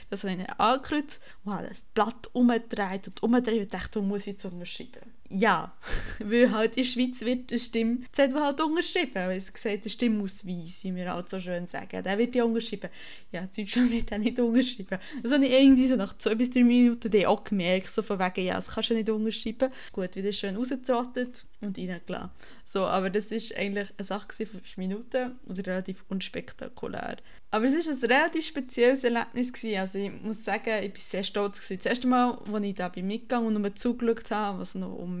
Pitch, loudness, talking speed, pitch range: 220 Hz, -28 LUFS, 215 wpm, 195-245 Hz